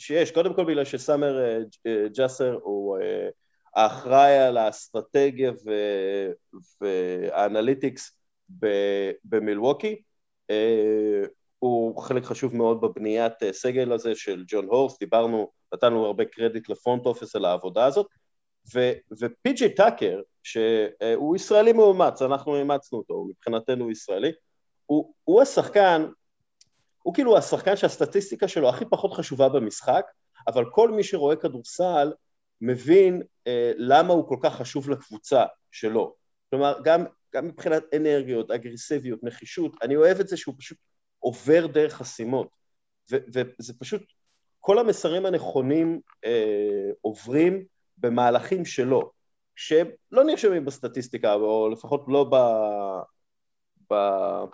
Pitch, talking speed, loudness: 140 Hz, 120 wpm, -24 LUFS